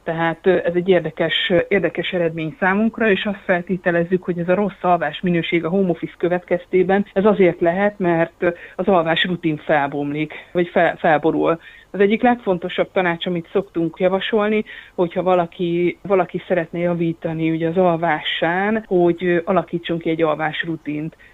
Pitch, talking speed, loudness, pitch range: 175 Hz, 145 wpm, -19 LUFS, 165-190 Hz